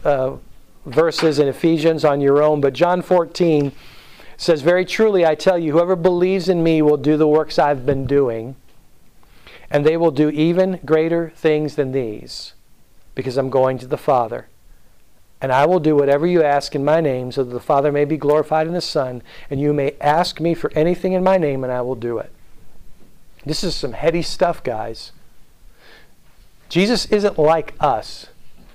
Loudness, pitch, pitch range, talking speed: -18 LUFS, 150 Hz, 140-170 Hz, 180 wpm